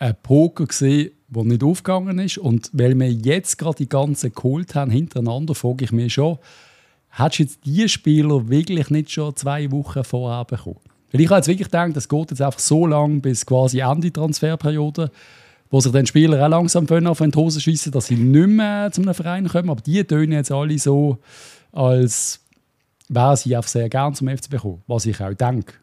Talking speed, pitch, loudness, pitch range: 200 wpm, 145 Hz, -18 LUFS, 125-160 Hz